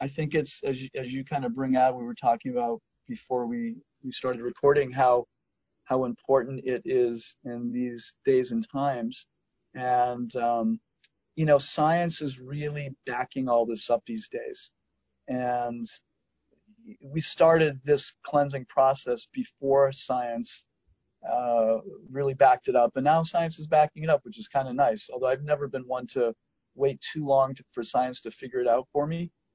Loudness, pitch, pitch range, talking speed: -27 LUFS, 135 Hz, 125-150 Hz, 175 wpm